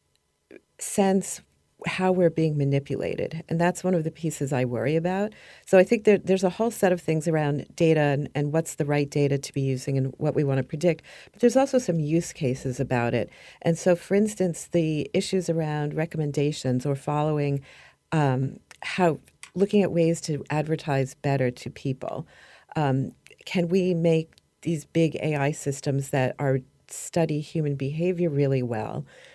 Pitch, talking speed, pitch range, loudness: 155 Hz, 170 wpm, 140-175 Hz, -25 LUFS